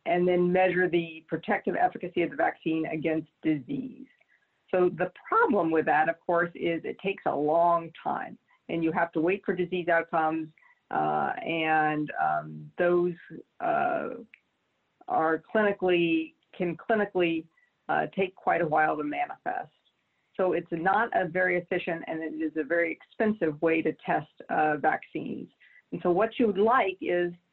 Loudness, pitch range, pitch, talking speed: -28 LUFS, 160-195 Hz, 175 Hz, 155 wpm